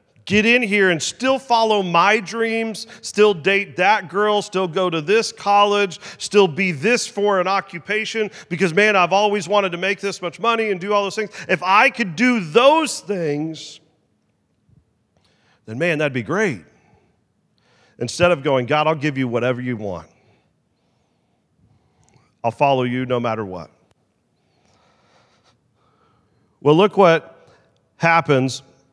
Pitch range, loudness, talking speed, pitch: 150-210 Hz, -18 LUFS, 145 wpm, 190 Hz